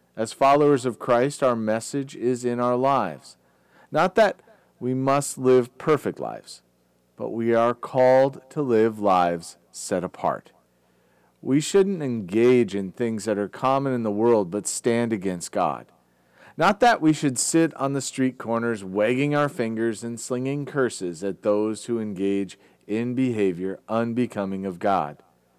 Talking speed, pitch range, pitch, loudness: 150 wpm, 100-130 Hz, 115 Hz, -23 LUFS